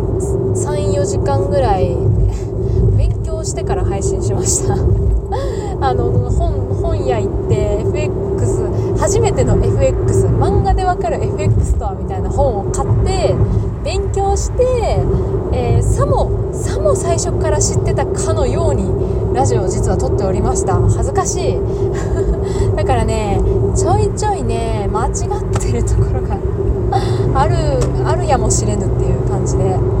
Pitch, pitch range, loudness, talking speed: 120 Hz, 100-125 Hz, -16 LUFS, 255 characters per minute